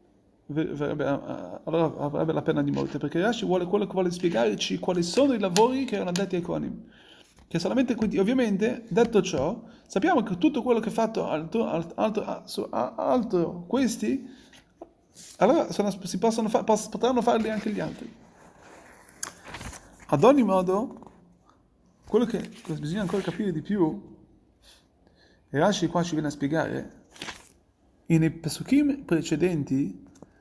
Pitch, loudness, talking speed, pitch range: 190 Hz, -26 LUFS, 140 wpm, 160-225 Hz